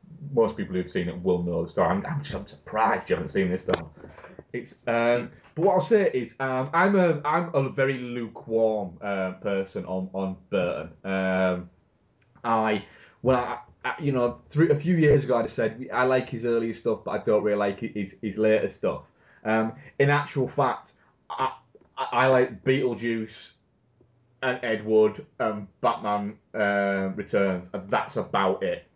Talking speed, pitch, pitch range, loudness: 170 wpm, 115 Hz, 100-130 Hz, -26 LUFS